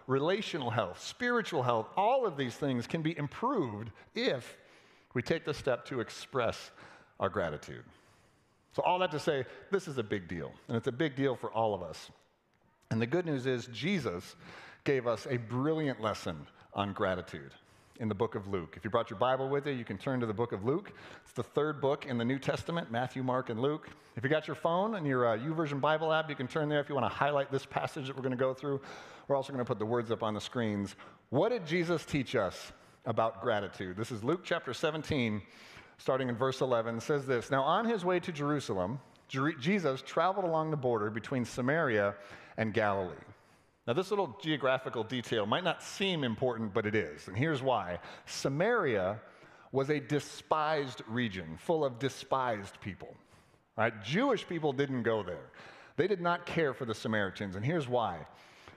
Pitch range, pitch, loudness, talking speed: 115-150 Hz, 130 Hz, -33 LUFS, 200 wpm